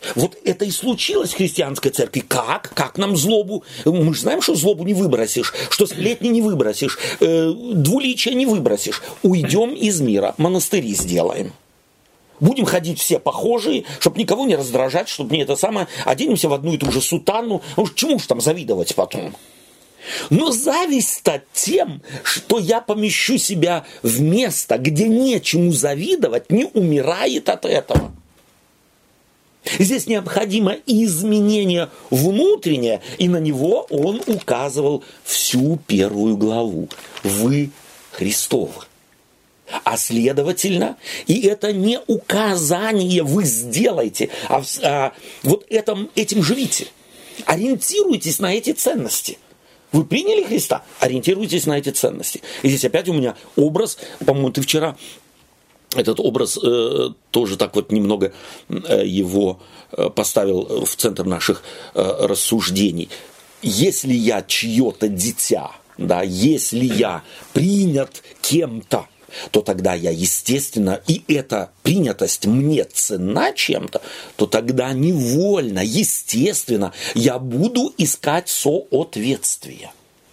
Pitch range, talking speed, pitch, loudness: 130-210 Hz, 120 wpm, 170 Hz, -18 LUFS